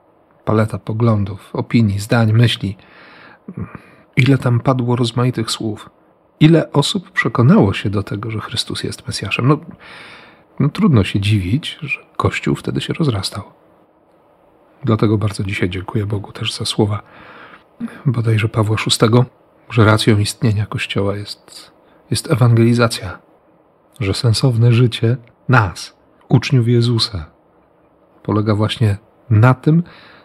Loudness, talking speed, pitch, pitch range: -16 LUFS, 115 wpm, 115 Hz, 105-125 Hz